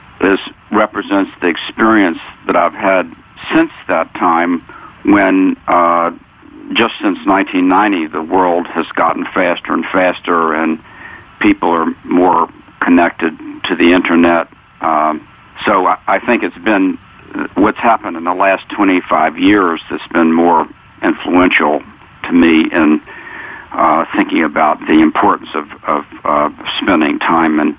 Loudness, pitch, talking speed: -13 LUFS, 110 Hz, 135 wpm